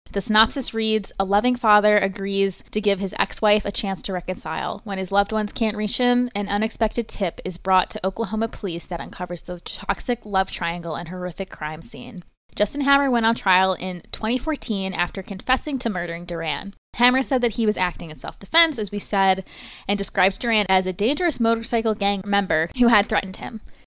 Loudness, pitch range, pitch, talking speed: -22 LUFS, 185-225 Hz, 200 Hz, 195 wpm